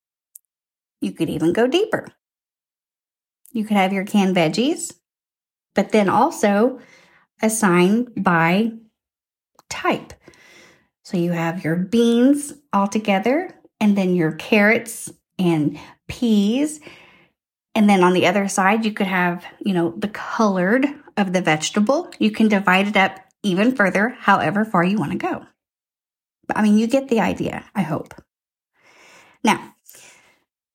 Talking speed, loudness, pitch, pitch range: 135 wpm, -19 LUFS, 205 Hz, 185-235 Hz